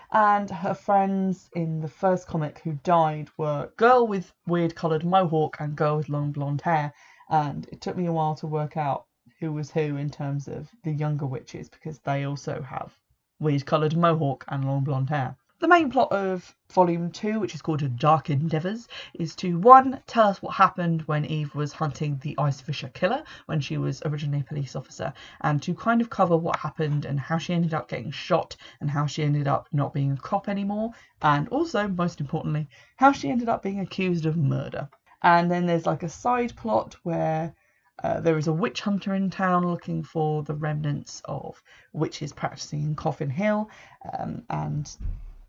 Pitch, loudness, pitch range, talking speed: 160 Hz, -25 LUFS, 150-185 Hz, 195 wpm